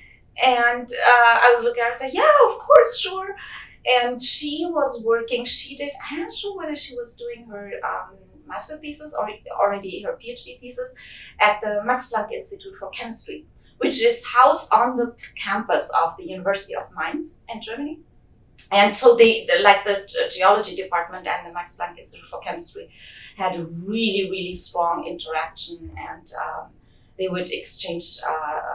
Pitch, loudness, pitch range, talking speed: 240 Hz, -21 LUFS, 200-310 Hz, 175 wpm